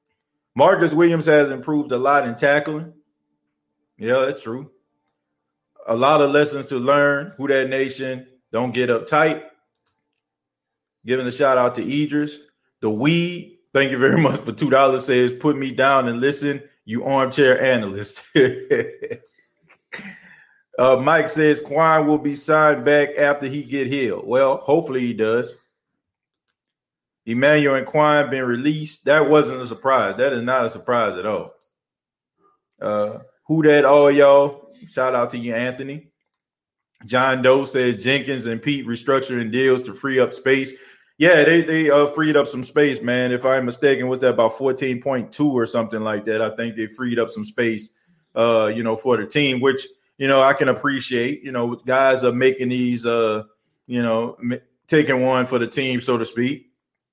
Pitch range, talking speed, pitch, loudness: 120-150 Hz, 170 wpm, 135 Hz, -19 LUFS